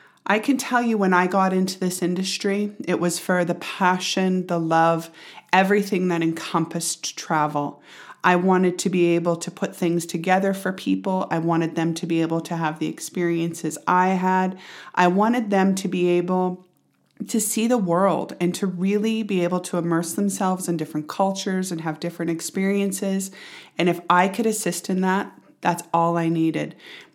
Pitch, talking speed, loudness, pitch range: 180 Hz, 175 wpm, -22 LUFS, 170-195 Hz